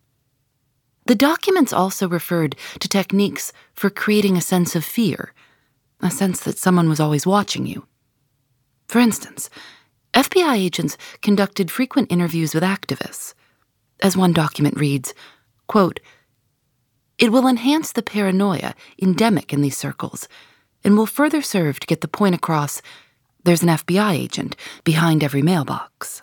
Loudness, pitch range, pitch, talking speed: -19 LUFS, 145-205 Hz, 180 Hz, 135 wpm